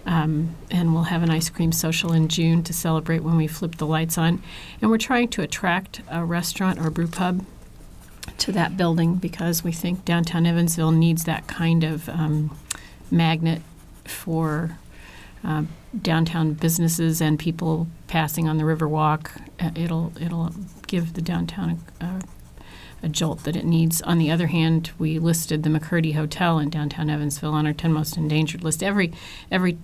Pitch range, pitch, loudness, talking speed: 160-170 Hz, 165 Hz, -23 LUFS, 170 wpm